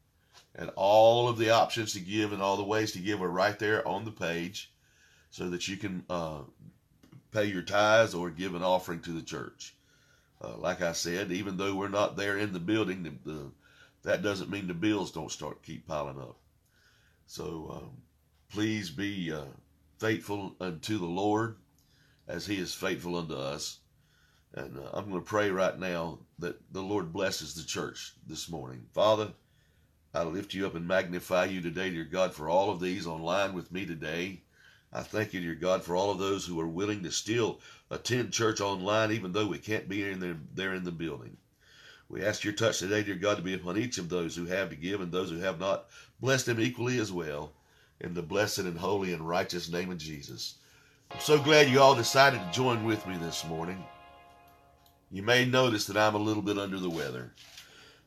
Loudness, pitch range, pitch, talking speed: -31 LUFS, 85-105 Hz, 95 Hz, 205 wpm